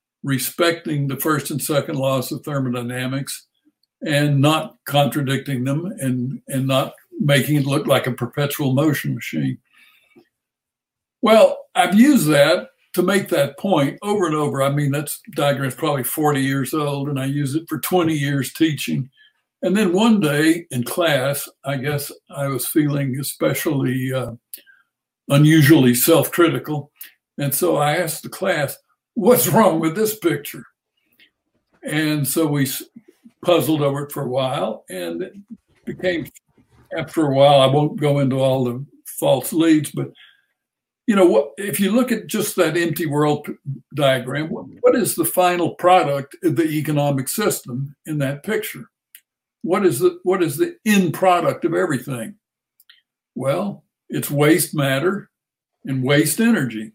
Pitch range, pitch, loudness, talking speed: 135-180 Hz, 150 Hz, -19 LUFS, 150 wpm